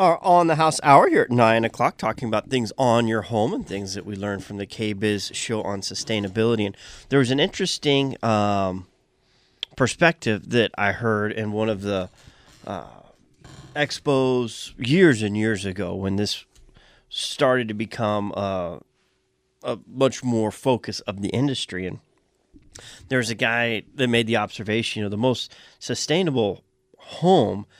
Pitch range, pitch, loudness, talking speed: 100-130 Hz, 110 Hz, -22 LUFS, 160 wpm